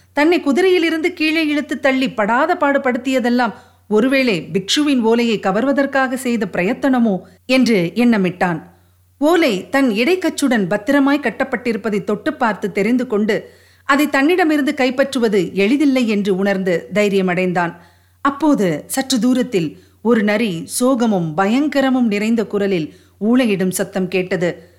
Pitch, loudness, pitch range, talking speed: 235 Hz, -16 LUFS, 195-275 Hz, 105 wpm